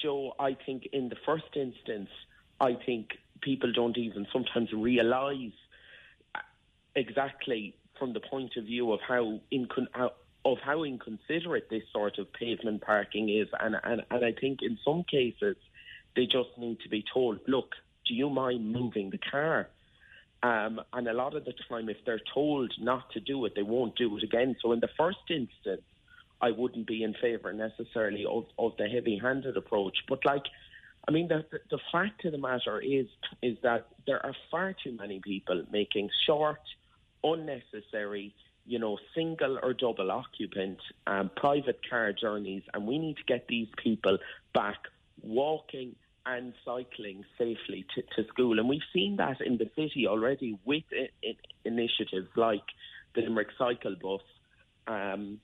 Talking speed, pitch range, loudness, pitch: 165 wpm, 110-135 Hz, -32 LUFS, 120 Hz